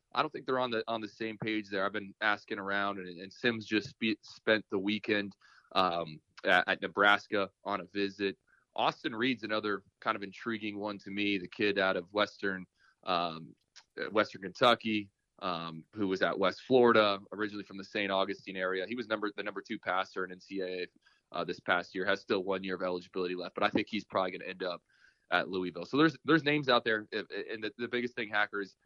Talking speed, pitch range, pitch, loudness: 210 wpm, 95-110 Hz, 100 Hz, -33 LUFS